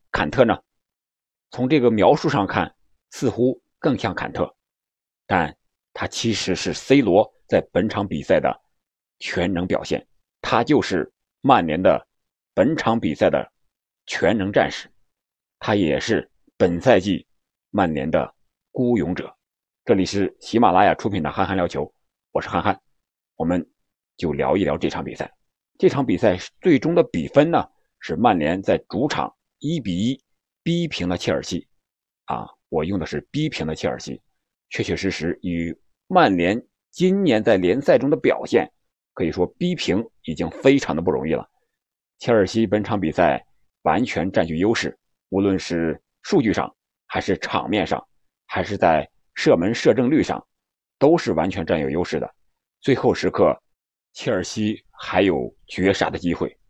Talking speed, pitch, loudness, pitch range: 225 characters per minute, 95 Hz, -21 LUFS, 90-125 Hz